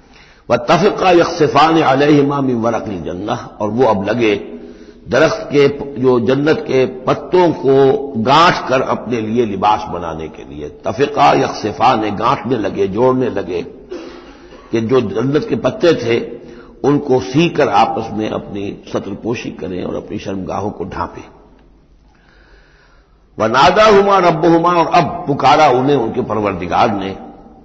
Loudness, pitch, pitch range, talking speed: -14 LUFS, 130 Hz, 110-155 Hz, 140 wpm